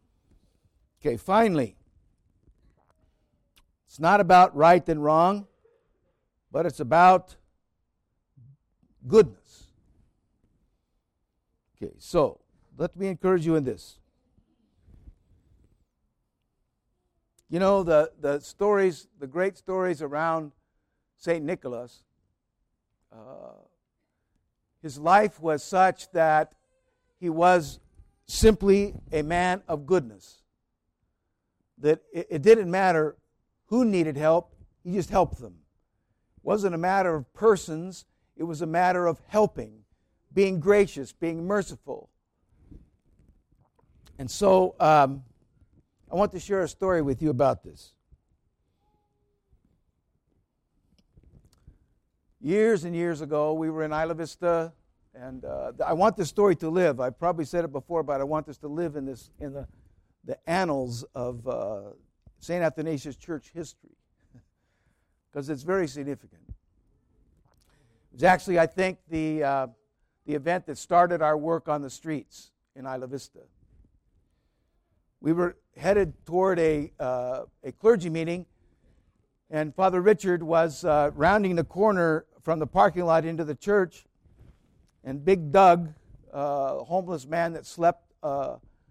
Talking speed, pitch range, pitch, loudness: 120 wpm, 125-180 Hz, 155 Hz, -25 LUFS